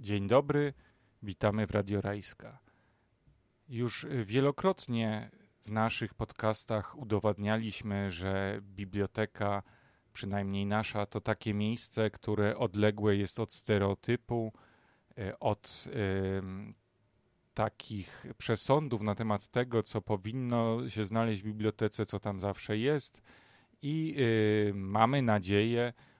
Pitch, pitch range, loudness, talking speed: 110 Hz, 100-120 Hz, -33 LUFS, 105 wpm